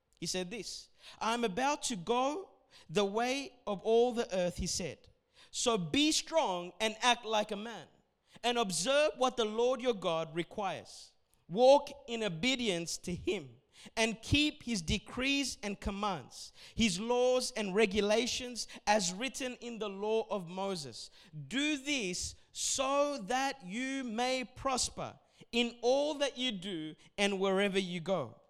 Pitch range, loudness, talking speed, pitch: 195-255 Hz, -33 LUFS, 145 wpm, 230 Hz